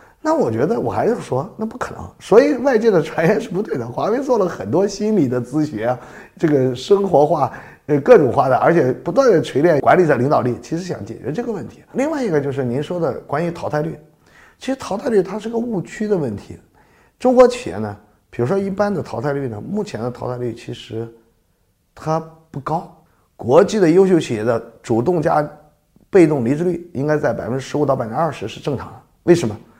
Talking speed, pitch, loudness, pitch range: 315 characters per minute, 150 Hz, -18 LUFS, 120-195 Hz